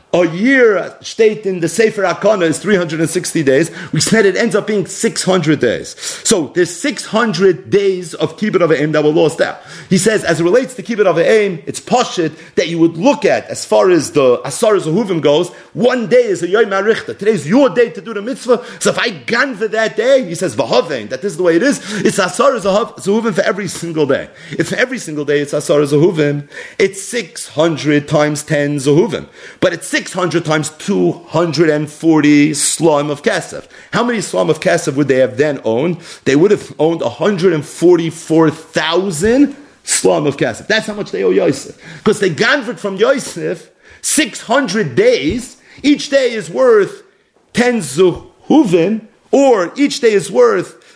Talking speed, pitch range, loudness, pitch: 175 wpm, 160-235 Hz, -14 LUFS, 190 Hz